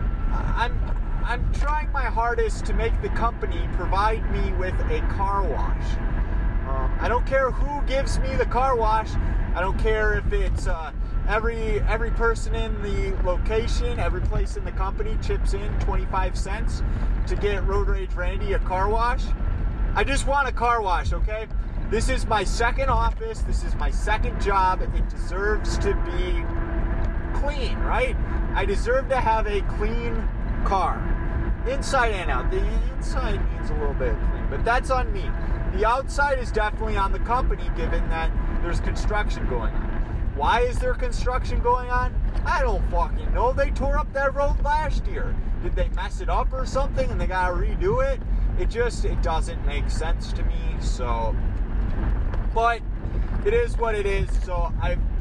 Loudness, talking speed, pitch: -25 LUFS, 170 wpm, 220 Hz